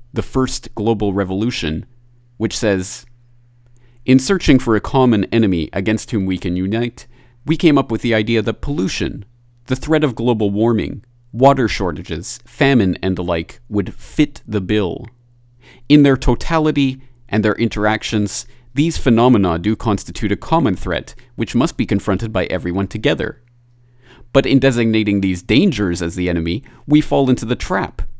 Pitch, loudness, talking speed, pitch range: 115 Hz, -17 LUFS, 155 wpm, 100-125 Hz